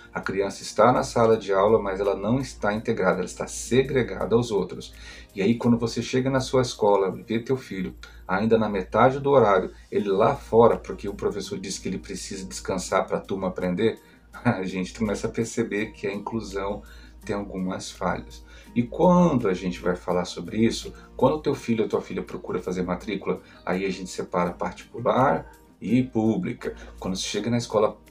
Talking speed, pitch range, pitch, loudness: 190 wpm, 95-120 Hz, 105 Hz, -25 LUFS